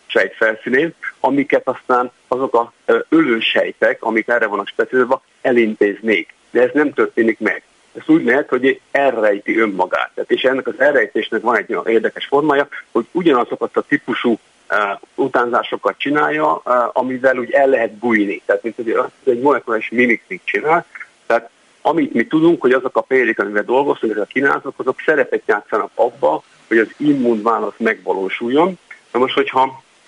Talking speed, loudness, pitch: 155 wpm, -17 LUFS, 140 Hz